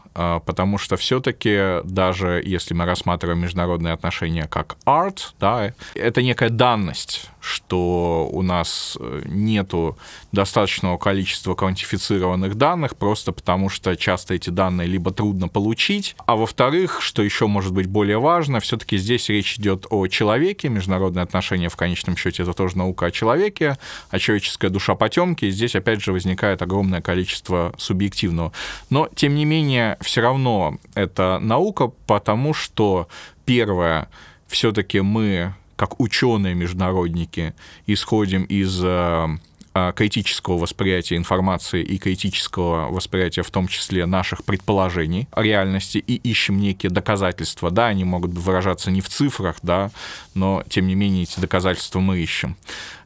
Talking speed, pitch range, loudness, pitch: 135 wpm, 90-105 Hz, -20 LUFS, 95 Hz